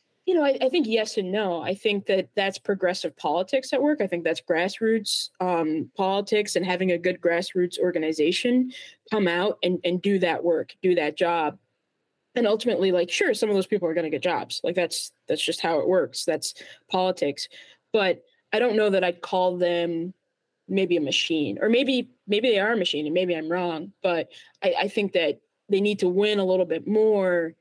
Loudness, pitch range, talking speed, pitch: -24 LUFS, 175-215 Hz, 205 wpm, 190 Hz